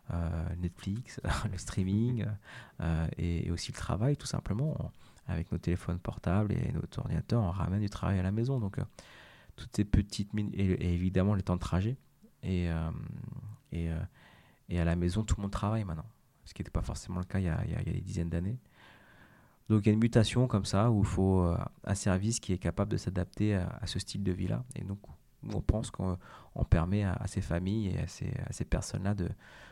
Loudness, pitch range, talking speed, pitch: -33 LUFS, 90-115 Hz, 225 wpm, 100 Hz